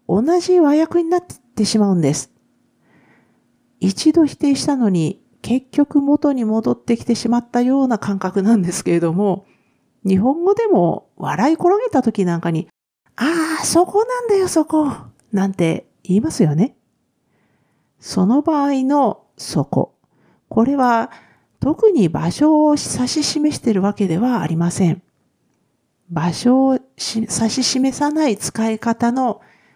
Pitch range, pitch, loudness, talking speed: 200-295 Hz, 245 Hz, -17 LUFS, 255 characters per minute